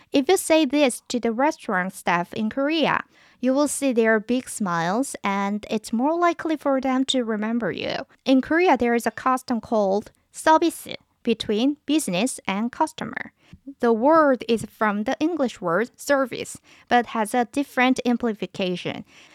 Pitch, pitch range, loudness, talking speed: 250 Hz, 220-285 Hz, -23 LUFS, 155 wpm